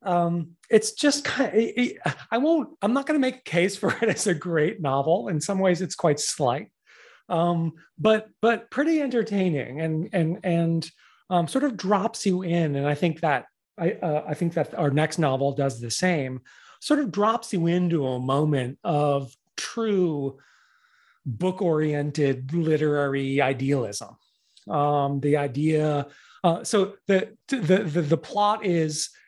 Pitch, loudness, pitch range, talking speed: 170 Hz, -24 LUFS, 150-205 Hz, 160 wpm